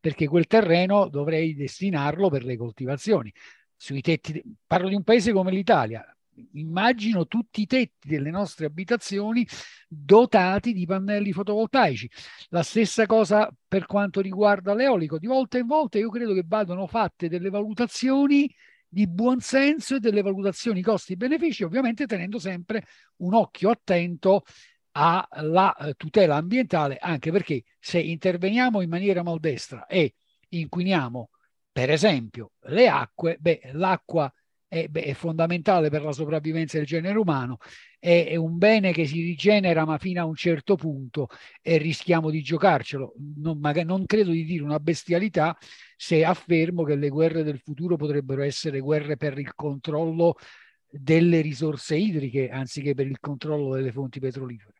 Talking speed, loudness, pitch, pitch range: 145 wpm, -24 LUFS, 170 Hz, 150-205 Hz